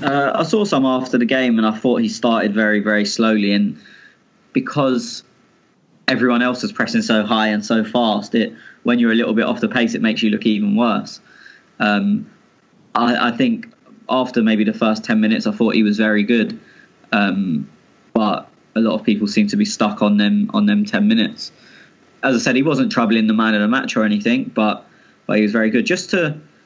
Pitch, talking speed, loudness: 125 Hz, 210 wpm, -17 LUFS